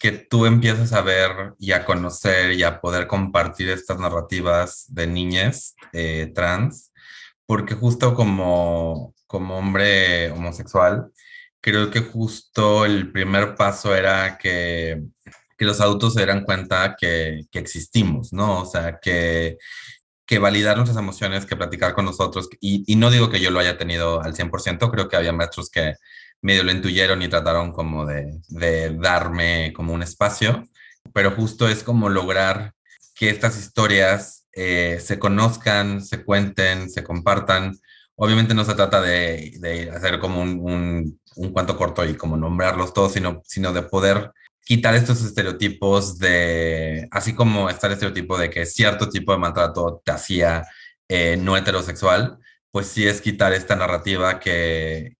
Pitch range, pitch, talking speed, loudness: 85-105 Hz, 95 Hz, 155 wpm, -20 LUFS